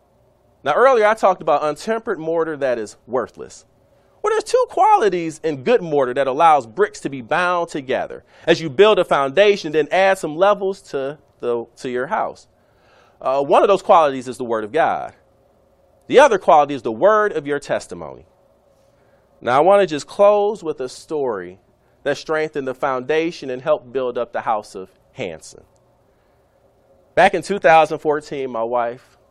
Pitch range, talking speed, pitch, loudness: 135-195 Hz, 170 wpm, 155 Hz, -18 LUFS